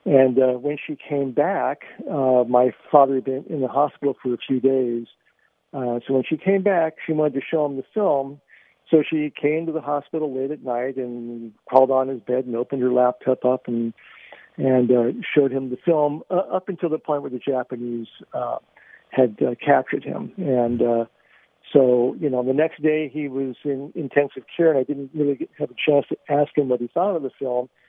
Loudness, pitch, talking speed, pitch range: -22 LUFS, 135 Hz, 215 wpm, 125-150 Hz